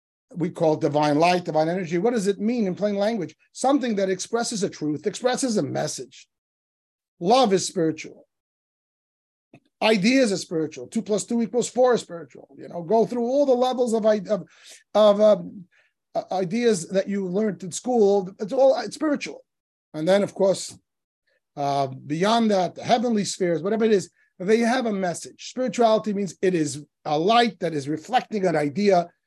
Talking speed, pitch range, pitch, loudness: 170 wpm, 170-230 Hz, 200 Hz, -23 LUFS